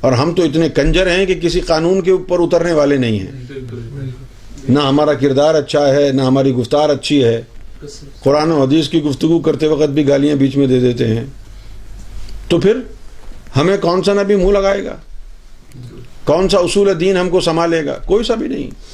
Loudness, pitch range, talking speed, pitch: -14 LUFS, 130-170 Hz, 190 wpm, 145 Hz